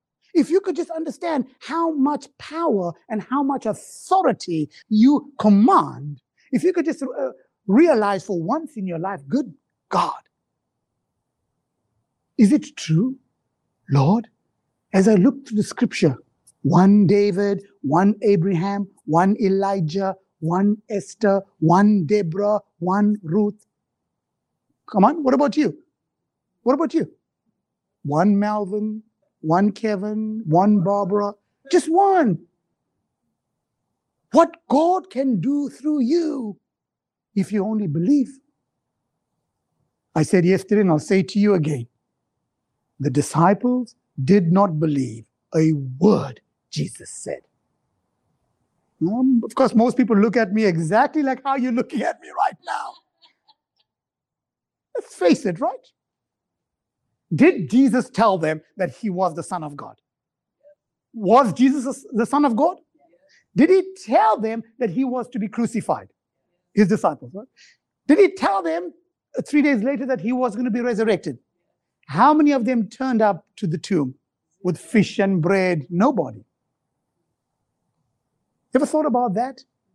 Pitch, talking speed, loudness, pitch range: 215 Hz, 130 wpm, -20 LUFS, 190-270 Hz